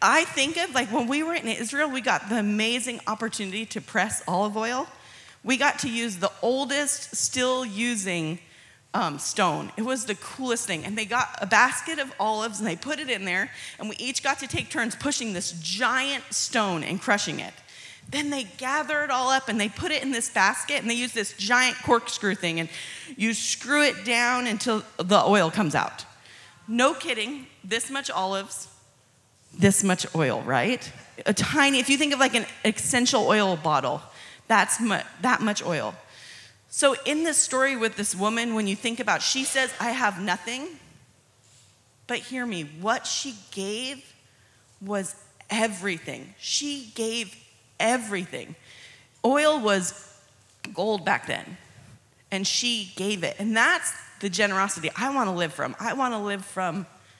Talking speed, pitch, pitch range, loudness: 175 wpm, 225 Hz, 195-260 Hz, -25 LUFS